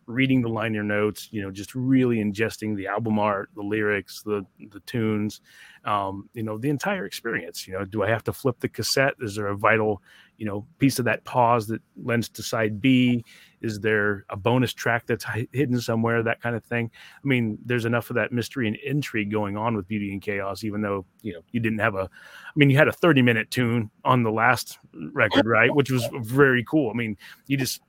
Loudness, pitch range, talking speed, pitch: -24 LUFS, 105-125 Hz, 220 wpm, 115 Hz